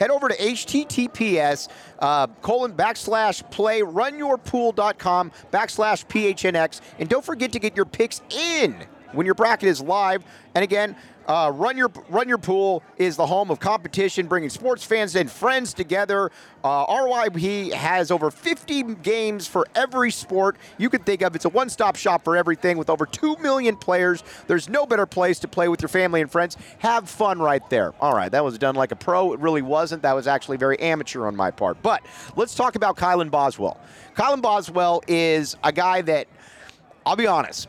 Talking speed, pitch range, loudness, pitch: 185 wpm, 170-225 Hz, -22 LUFS, 190 Hz